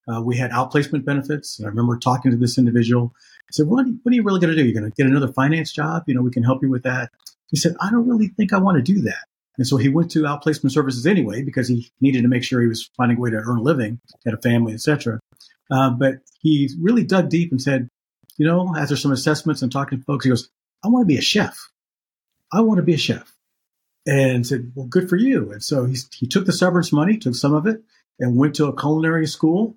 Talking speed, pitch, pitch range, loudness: 265 wpm, 140 Hz, 125-165 Hz, -19 LUFS